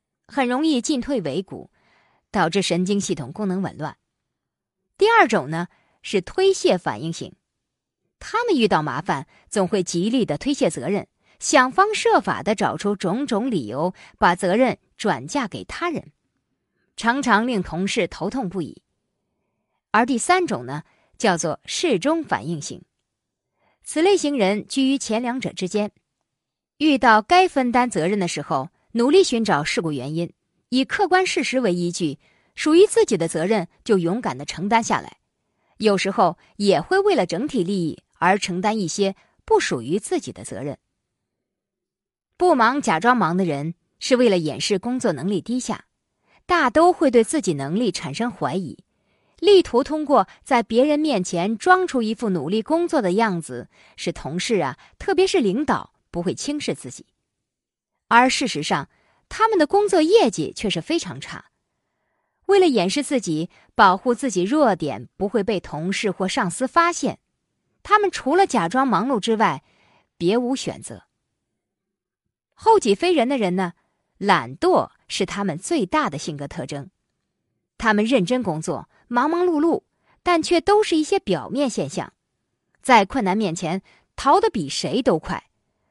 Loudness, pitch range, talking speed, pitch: -21 LUFS, 180-305 Hz, 225 characters per minute, 225 Hz